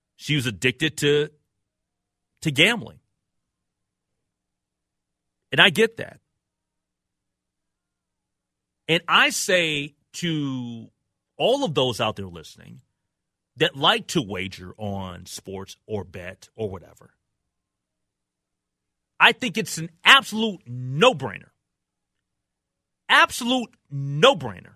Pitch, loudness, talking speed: 130 Hz, -20 LUFS, 90 wpm